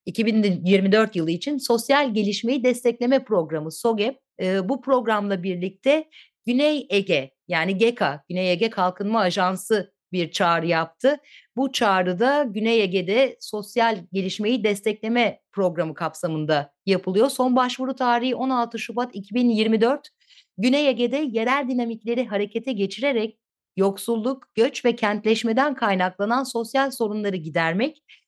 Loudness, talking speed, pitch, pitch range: -22 LUFS, 110 wpm, 225 Hz, 195-255 Hz